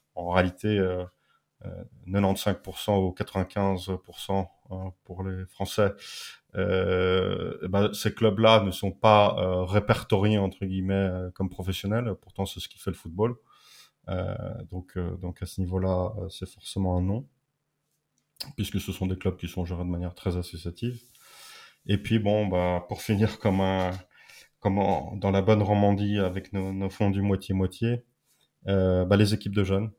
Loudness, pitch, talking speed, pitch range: -27 LUFS, 95 Hz, 170 wpm, 90-105 Hz